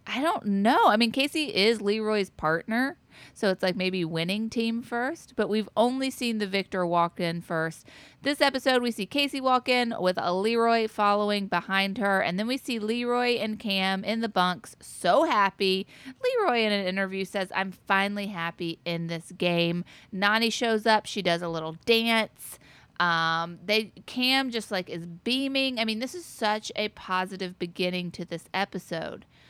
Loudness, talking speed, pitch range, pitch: -26 LUFS, 175 wpm, 180-230 Hz, 205 Hz